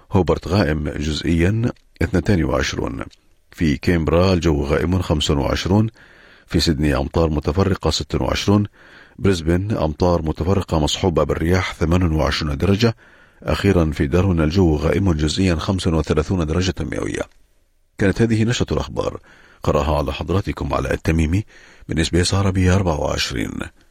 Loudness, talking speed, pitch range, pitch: -19 LUFS, 110 wpm, 75-95 Hz, 85 Hz